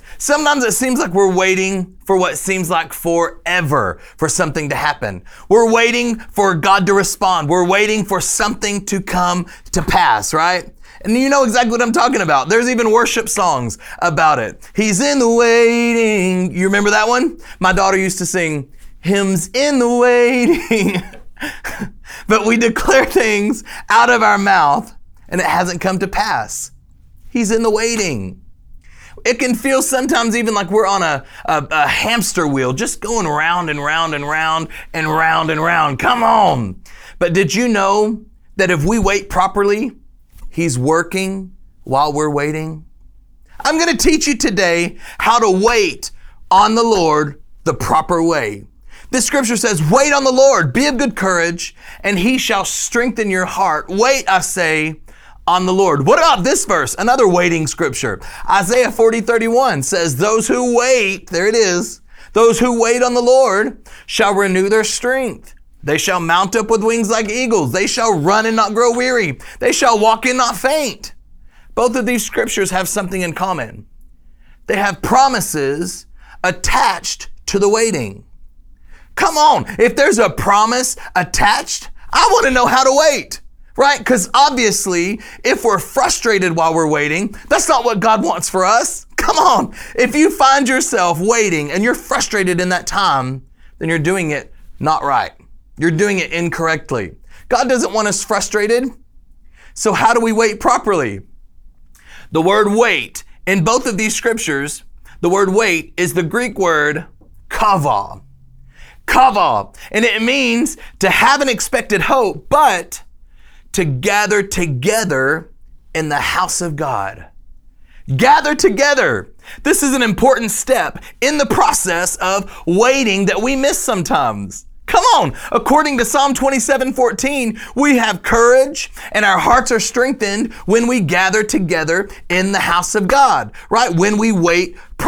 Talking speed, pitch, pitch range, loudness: 160 wpm, 205 Hz, 175-245 Hz, -14 LUFS